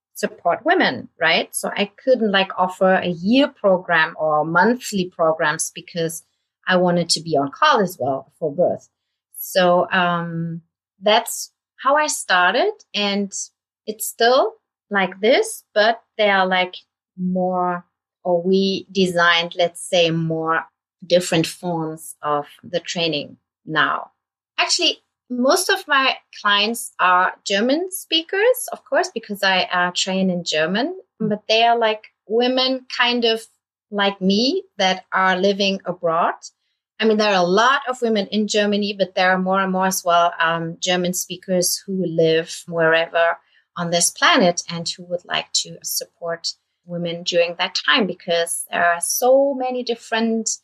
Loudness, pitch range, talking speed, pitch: -19 LUFS, 175-225 Hz, 150 wpm, 190 Hz